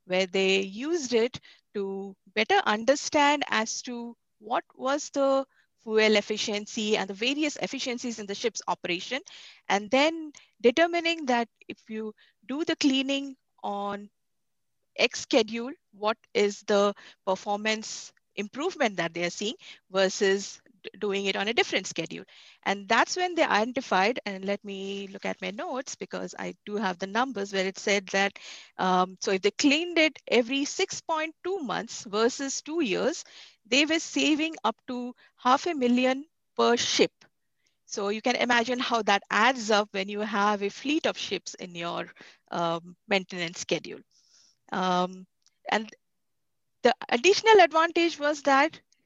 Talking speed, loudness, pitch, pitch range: 150 wpm, -27 LUFS, 225 Hz, 200-275 Hz